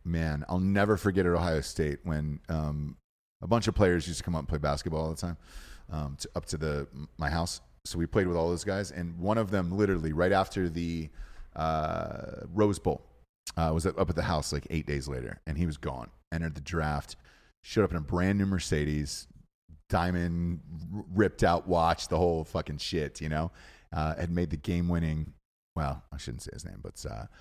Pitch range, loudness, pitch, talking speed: 75-90 Hz, -31 LUFS, 85 Hz, 210 wpm